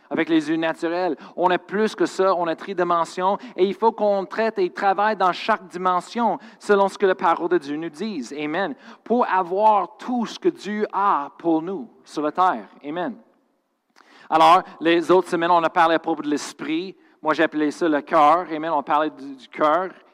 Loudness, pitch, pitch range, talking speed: -21 LUFS, 185 Hz, 165-215 Hz, 195 wpm